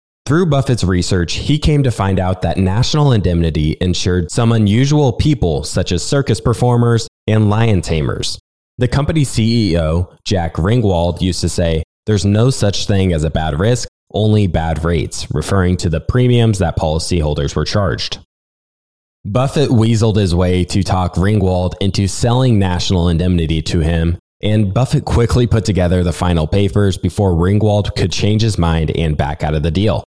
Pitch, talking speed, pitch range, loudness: 95 Hz, 165 wpm, 85-115 Hz, -15 LUFS